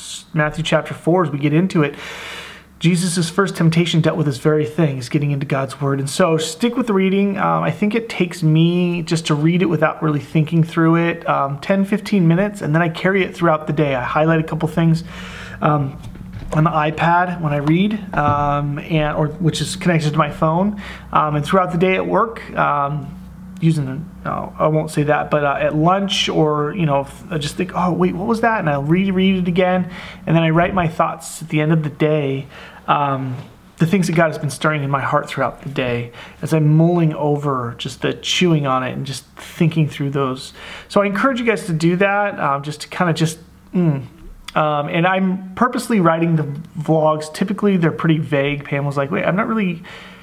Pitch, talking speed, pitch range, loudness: 160 Hz, 220 wpm, 150-180 Hz, -18 LUFS